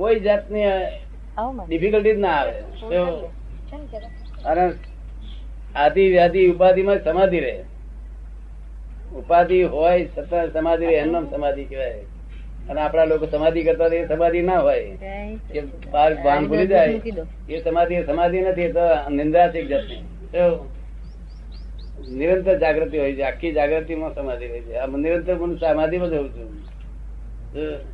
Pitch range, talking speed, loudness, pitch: 135-175 Hz, 85 wpm, -20 LUFS, 160 Hz